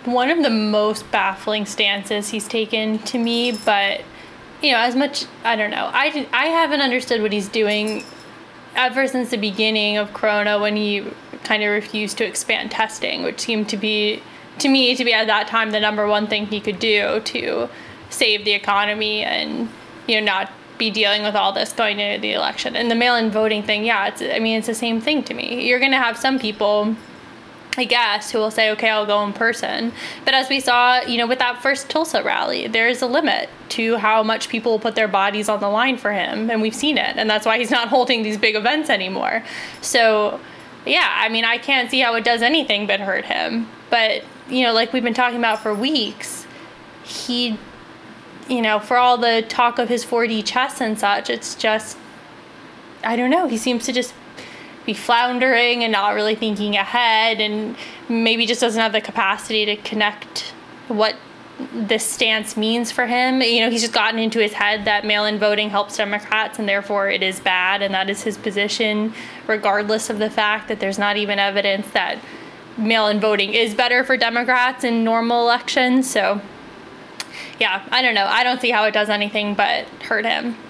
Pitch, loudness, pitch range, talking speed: 225 Hz, -18 LUFS, 210-245 Hz, 205 wpm